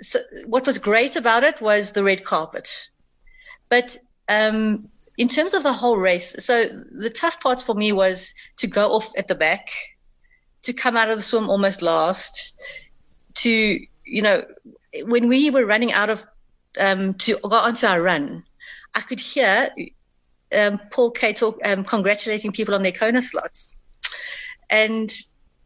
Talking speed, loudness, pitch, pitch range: 160 wpm, -20 LUFS, 230 Hz, 210-255 Hz